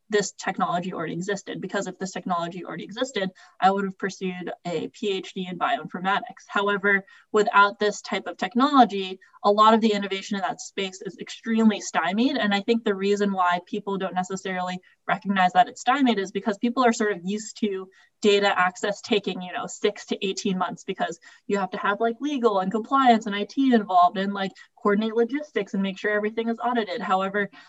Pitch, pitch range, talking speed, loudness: 205 Hz, 190-225 Hz, 190 wpm, -24 LUFS